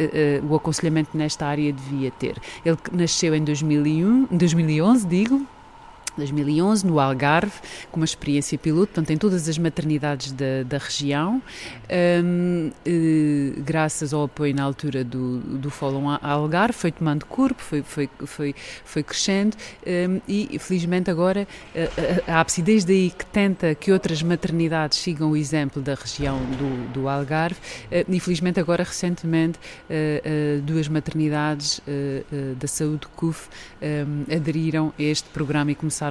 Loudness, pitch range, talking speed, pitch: -23 LUFS, 145-175 Hz, 135 wpm, 155 Hz